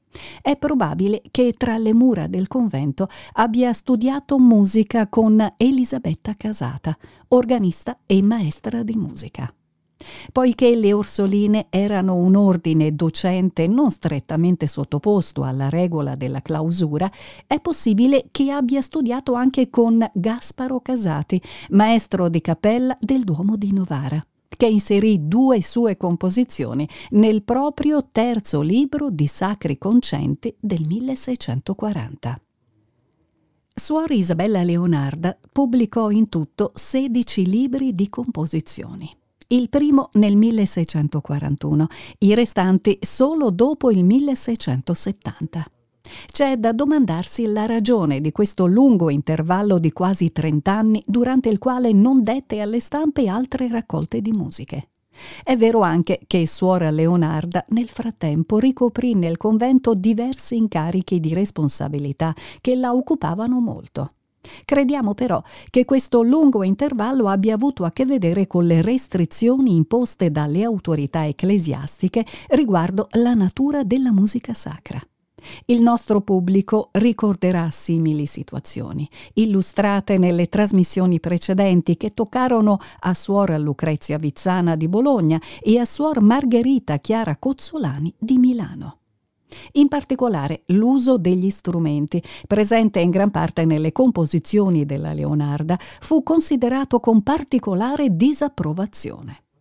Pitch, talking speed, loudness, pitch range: 205 Hz, 115 wpm, -19 LUFS, 165-245 Hz